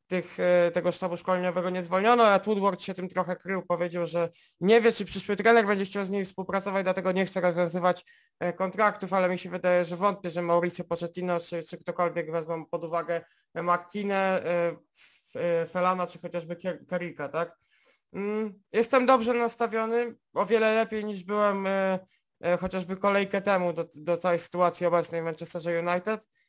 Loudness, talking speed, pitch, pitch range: -27 LUFS, 155 wpm, 180 Hz, 175-200 Hz